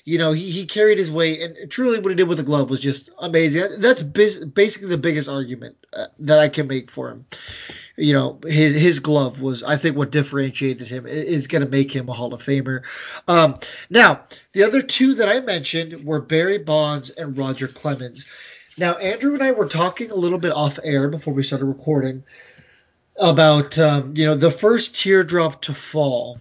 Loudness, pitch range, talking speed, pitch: -19 LUFS, 140-175 Hz, 205 wpm, 155 Hz